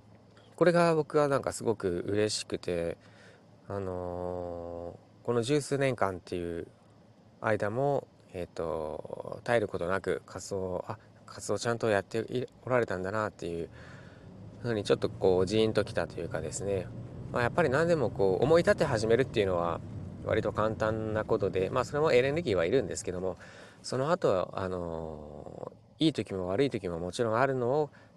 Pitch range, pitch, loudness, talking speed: 95-130 Hz, 105 Hz, -30 LUFS, 345 characters per minute